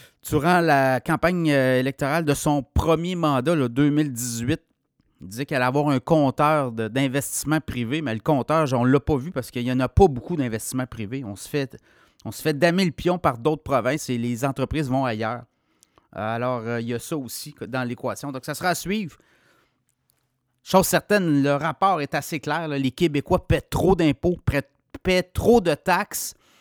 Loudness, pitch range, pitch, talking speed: -23 LUFS, 125-160 Hz, 140 Hz, 190 wpm